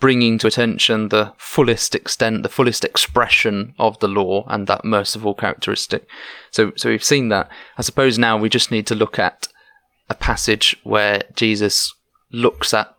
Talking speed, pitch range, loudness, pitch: 165 wpm, 105-120 Hz, -17 LUFS, 110 Hz